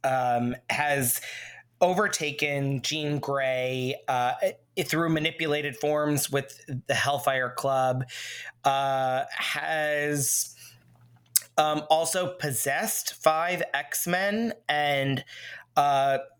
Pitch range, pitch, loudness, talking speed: 135-160 Hz, 145 Hz, -26 LUFS, 80 wpm